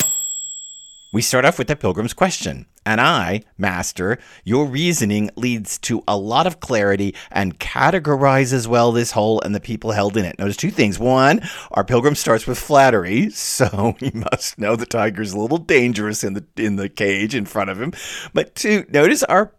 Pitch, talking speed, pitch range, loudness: 110 Hz, 185 wpm, 100-130 Hz, -18 LUFS